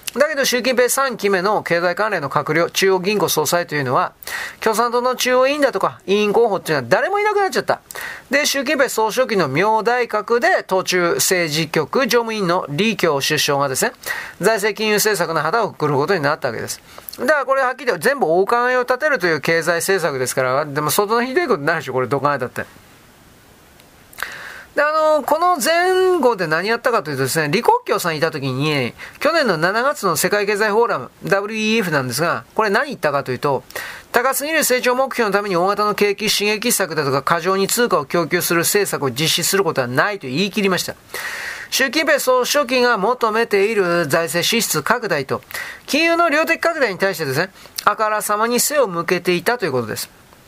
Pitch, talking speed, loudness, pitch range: 205 Hz, 395 characters per minute, -17 LUFS, 170-250 Hz